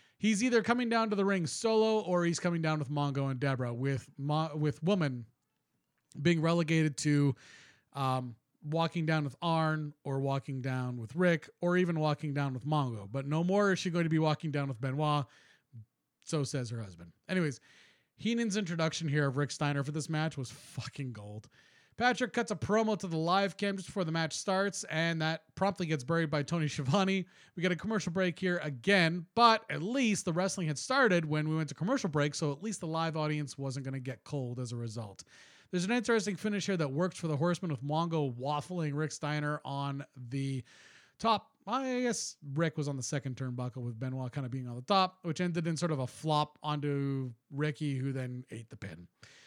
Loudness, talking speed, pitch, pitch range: -33 LUFS, 205 wpm, 155 Hz, 135-180 Hz